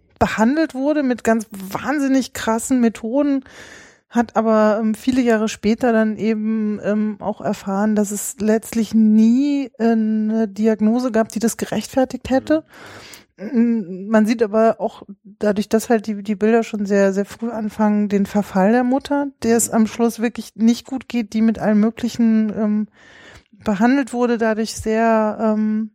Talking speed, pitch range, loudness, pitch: 155 wpm, 215-235 Hz, -19 LUFS, 225 Hz